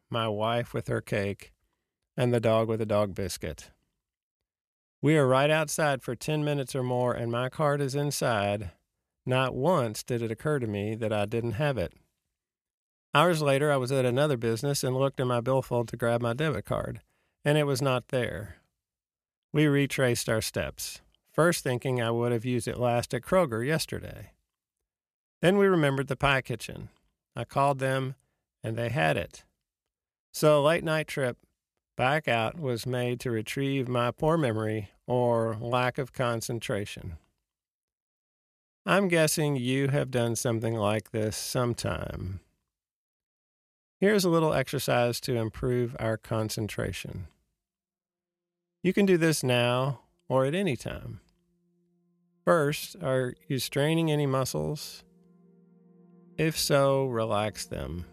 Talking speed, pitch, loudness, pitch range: 145 wpm, 125 Hz, -28 LUFS, 110-145 Hz